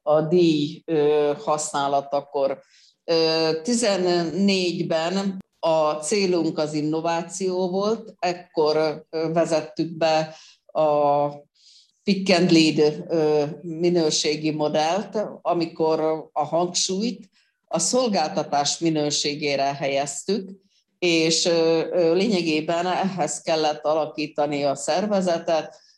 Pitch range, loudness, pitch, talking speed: 150-180 Hz, -22 LUFS, 160 Hz, 70 wpm